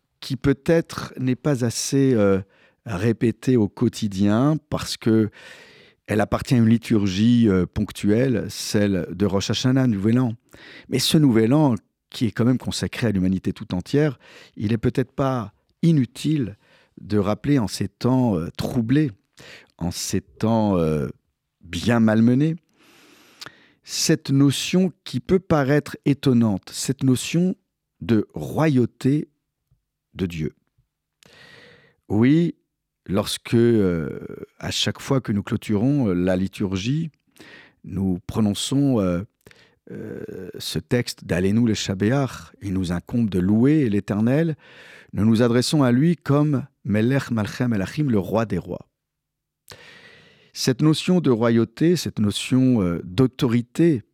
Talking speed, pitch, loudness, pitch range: 125 wpm, 120 Hz, -21 LUFS, 105-140 Hz